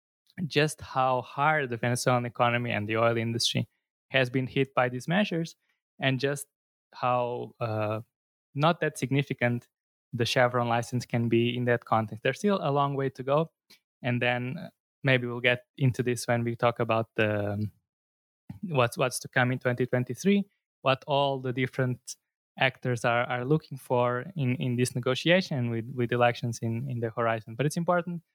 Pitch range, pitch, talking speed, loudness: 120-140 Hz, 125 Hz, 165 wpm, -28 LUFS